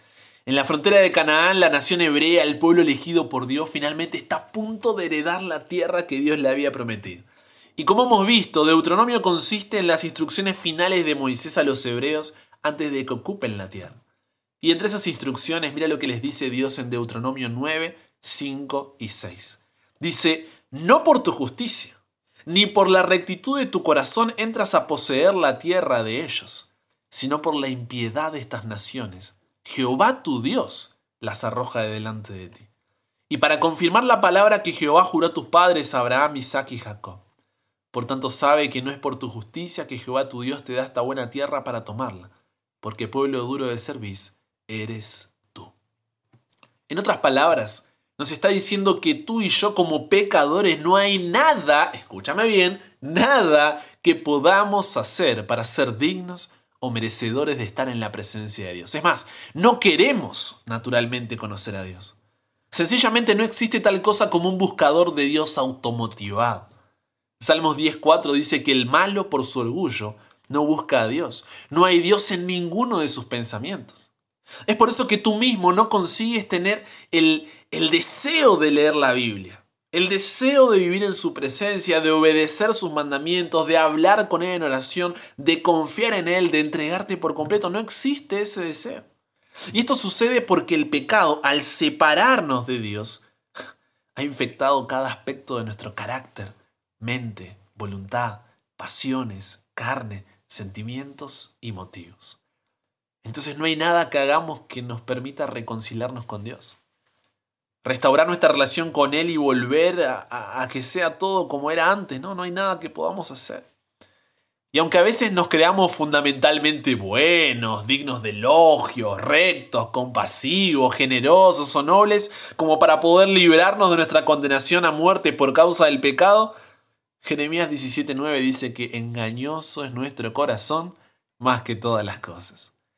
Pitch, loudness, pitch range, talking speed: 145 Hz, -20 LUFS, 120-180 Hz, 160 wpm